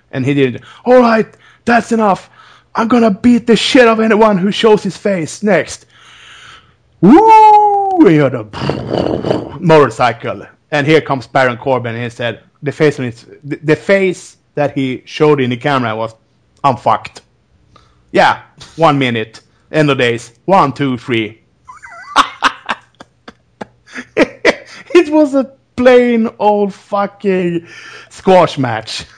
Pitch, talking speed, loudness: 155 Hz, 130 wpm, -12 LUFS